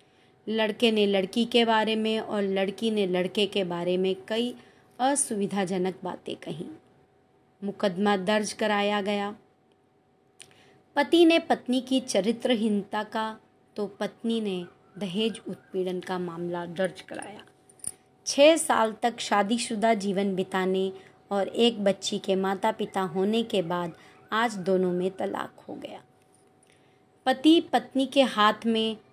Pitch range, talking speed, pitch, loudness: 190-230 Hz, 130 wpm, 205 Hz, -26 LUFS